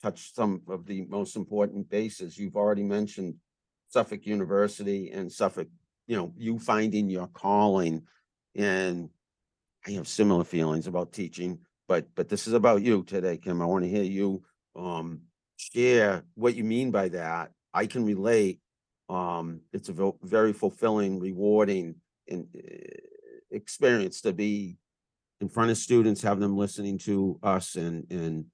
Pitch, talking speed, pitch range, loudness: 100 Hz, 145 wpm, 90-105 Hz, -28 LUFS